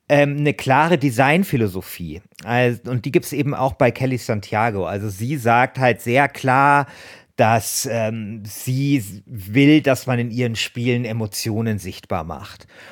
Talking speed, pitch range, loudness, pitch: 140 wpm, 110-135 Hz, -19 LUFS, 120 Hz